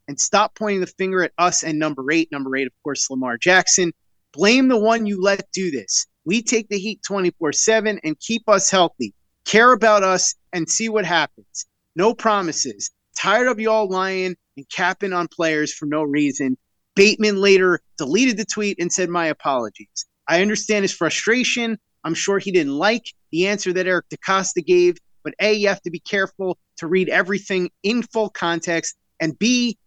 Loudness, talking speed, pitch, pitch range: -19 LUFS, 185 wpm, 185 Hz, 165-215 Hz